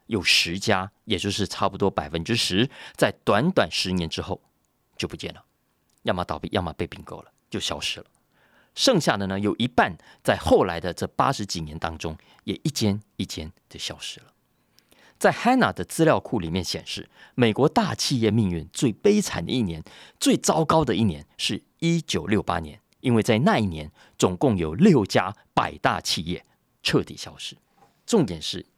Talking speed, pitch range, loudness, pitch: 265 characters per minute, 85-115 Hz, -24 LUFS, 100 Hz